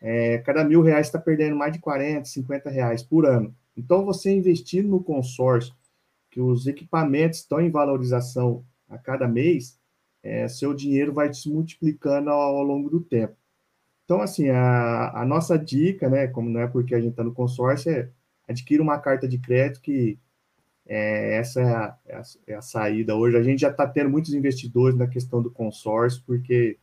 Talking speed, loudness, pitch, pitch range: 185 wpm, -23 LUFS, 135 Hz, 120-150 Hz